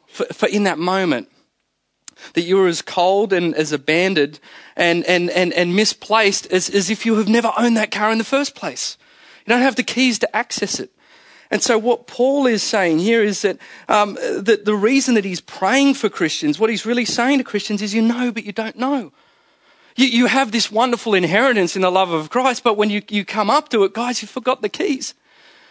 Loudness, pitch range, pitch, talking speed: -17 LUFS, 190-245 Hz, 220 Hz, 215 wpm